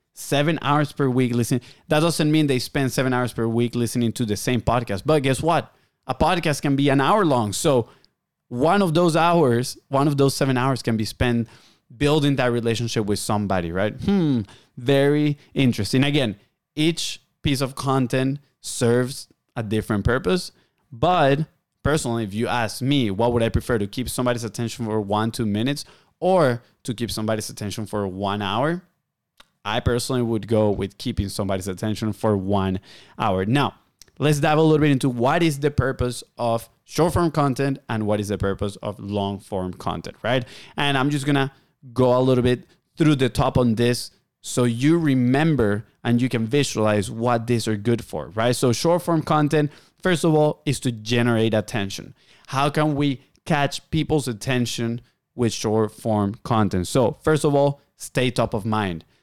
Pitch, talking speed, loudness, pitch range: 125 Hz, 180 wpm, -22 LUFS, 110-145 Hz